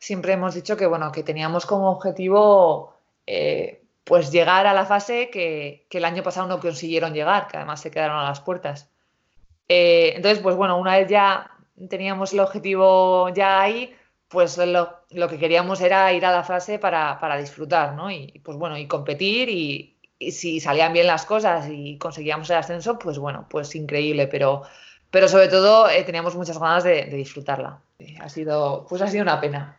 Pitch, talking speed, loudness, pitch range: 180 Hz, 190 wpm, -20 LUFS, 155-195 Hz